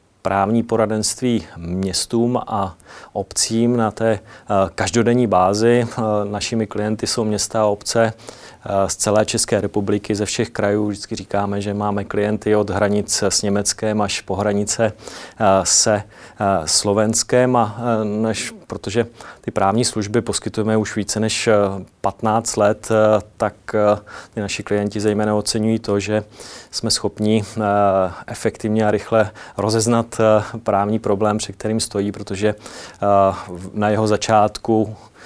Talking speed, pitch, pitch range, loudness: 120 wpm, 105 Hz, 100-110 Hz, -19 LUFS